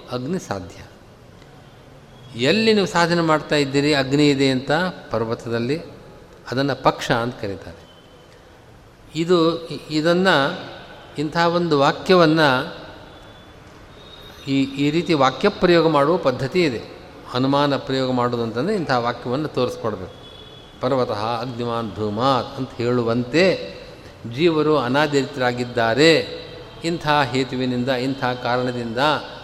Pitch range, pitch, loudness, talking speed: 125-160 Hz, 135 Hz, -20 LUFS, 90 wpm